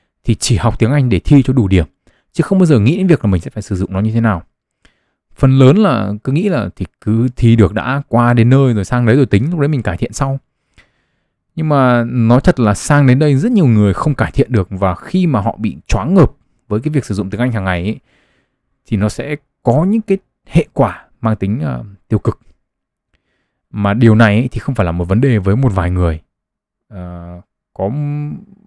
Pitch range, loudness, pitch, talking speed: 100-140 Hz, -14 LUFS, 115 Hz, 240 wpm